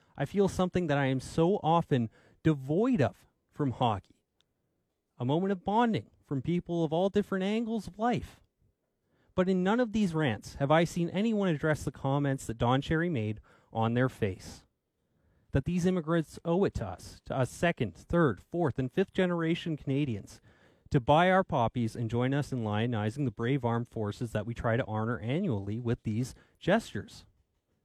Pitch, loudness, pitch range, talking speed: 140 Hz, -30 LUFS, 115-170 Hz, 175 wpm